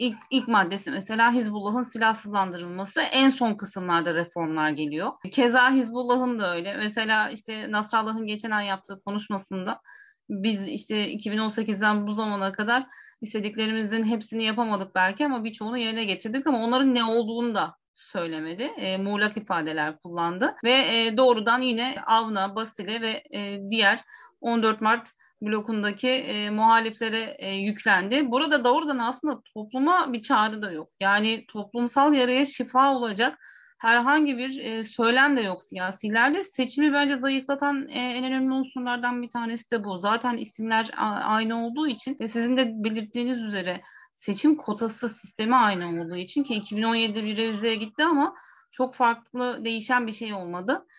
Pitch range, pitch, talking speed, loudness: 210-255 Hz, 225 Hz, 145 wpm, -25 LUFS